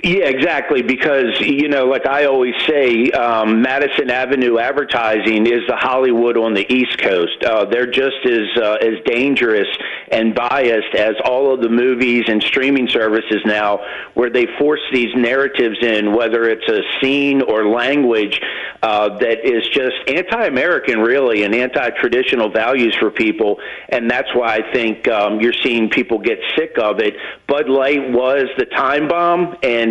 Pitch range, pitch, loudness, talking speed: 110-135 Hz, 120 Hz, -15 LUFS, 165 wpm